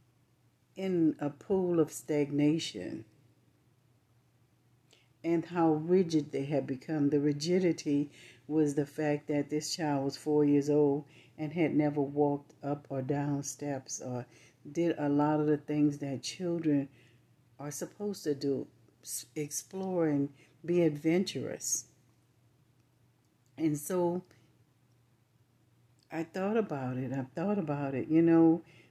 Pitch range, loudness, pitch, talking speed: 125-155 Hz, -32 LUFS, 145 Hz, 120 wpm